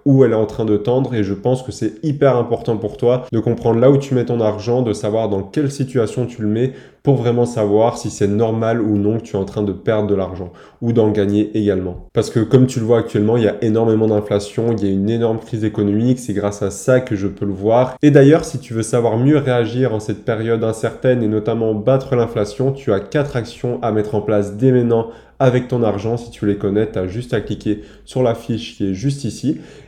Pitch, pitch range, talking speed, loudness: 115 Hz, 105-125 Hz, 255 wpm, -17 LUFS